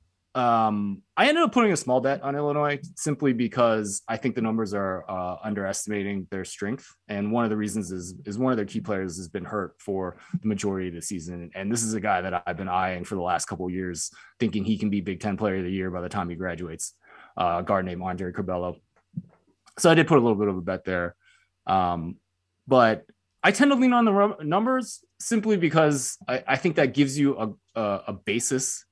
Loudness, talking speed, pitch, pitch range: -25 LUFS, 225 wpm, 105 Hz, 95-140 Hz